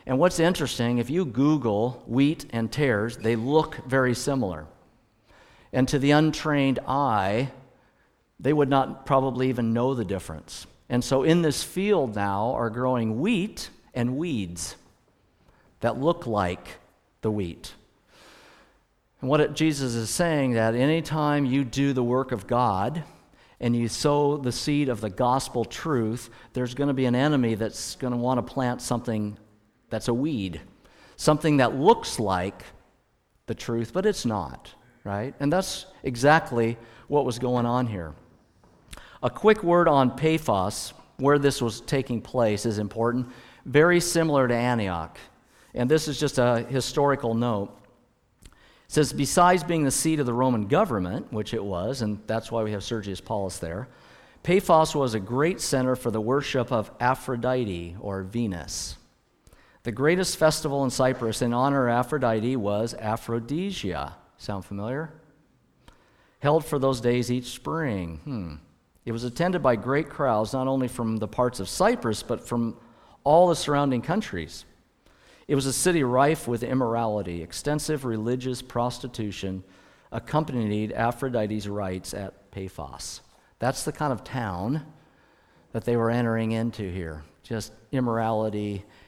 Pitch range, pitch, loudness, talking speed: 110-145 Hz, 125 Hz, -25 LUFS, 150 wpm